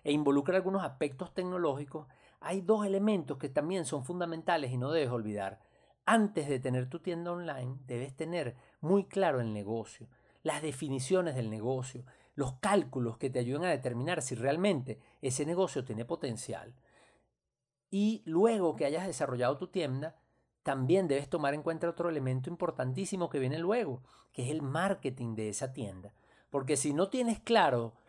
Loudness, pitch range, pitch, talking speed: -33 LUFS, 125-175 Hz, 145 Hz, 160 wpm